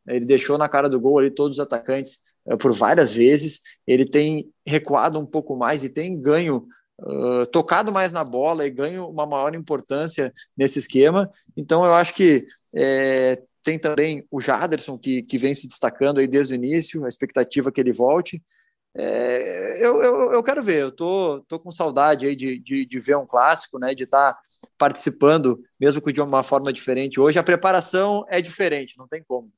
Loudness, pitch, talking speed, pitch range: -20 LUFS, 145 Hz, 195 wpm, 135-165 Hz